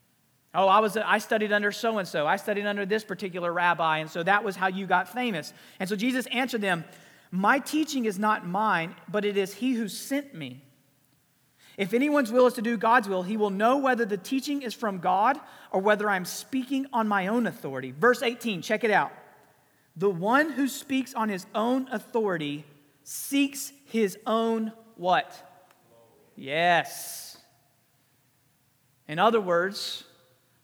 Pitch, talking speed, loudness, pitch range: 205 Hz, 165 wpm, -26 LUFS, 170-230 Hz